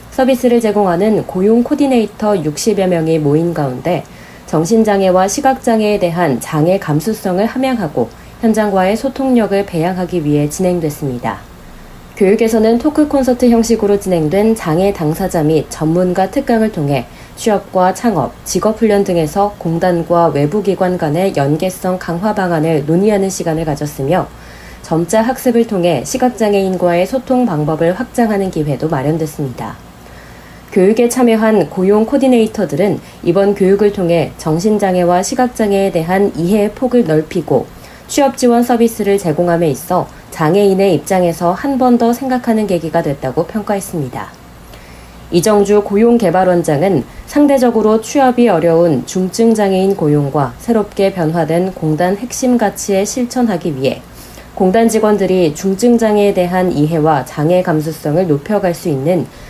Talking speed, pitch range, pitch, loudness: 330 characters per minute, 160-220 Hz, 185 Hz, -13 LUFS